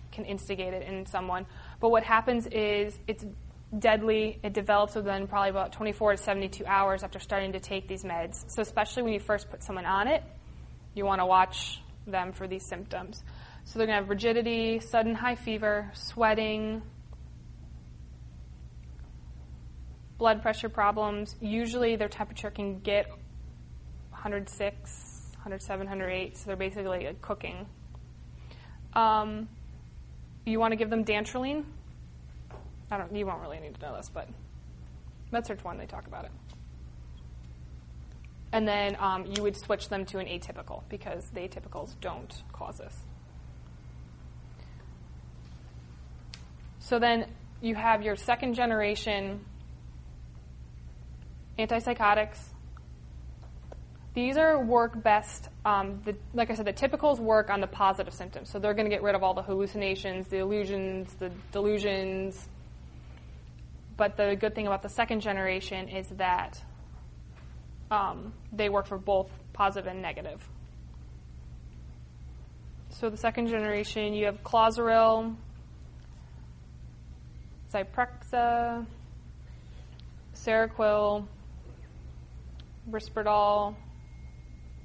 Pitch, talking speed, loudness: 190 Hz, 125 wpm, -30 LUFS